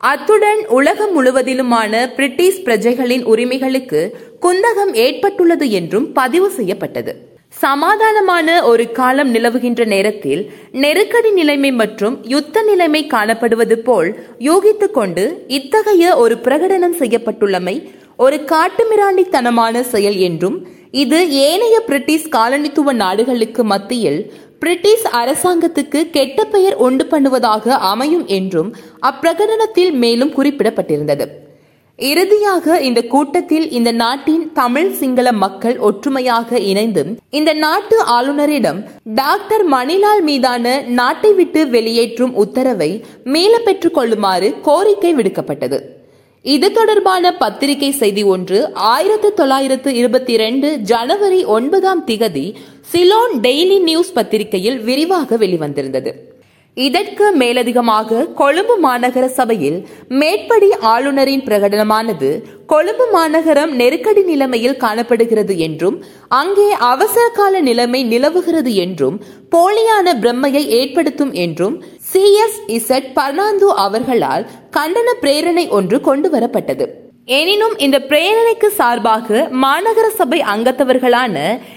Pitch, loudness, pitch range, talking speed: 275 Hz, -13 LUFS, 235-360 Hz, 95 wpm